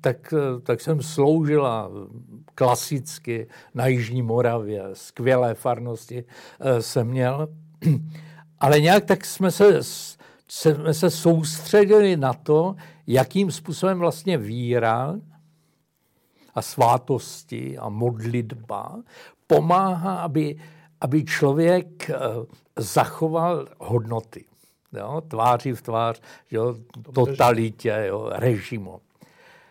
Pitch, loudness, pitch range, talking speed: 145 Hz, -22 LUFS, 120-165 Hz, 85 wpm